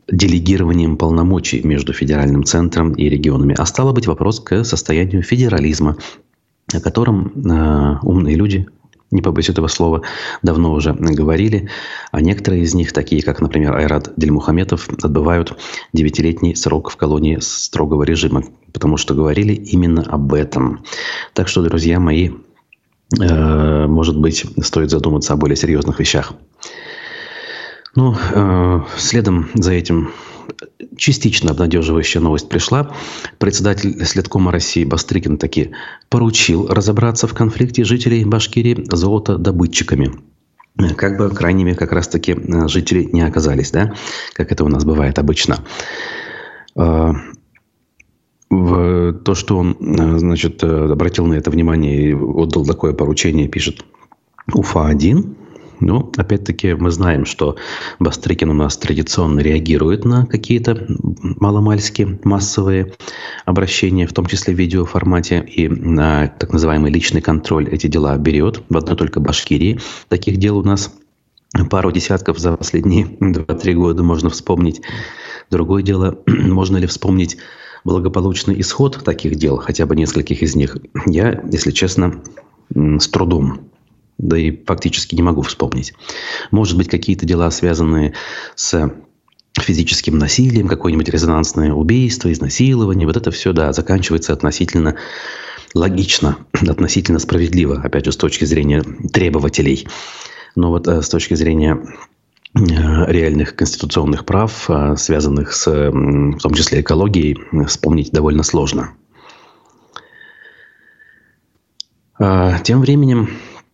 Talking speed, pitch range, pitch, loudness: 120 wpm, 80-95 Hz, 85 Hz, -15 LUFS